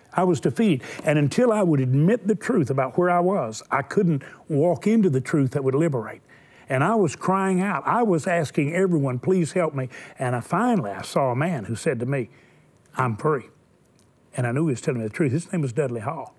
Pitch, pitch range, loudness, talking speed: 155 Hz, 135-180 Hz, -23 LUFS, 225 wpm